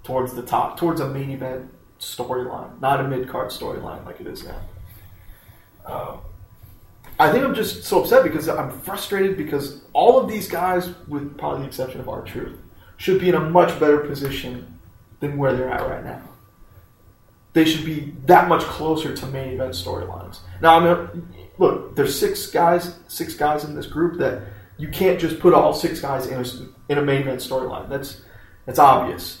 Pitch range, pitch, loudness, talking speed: 115-165 Hz, 135 Hz, -20 LUFS, 185 wpm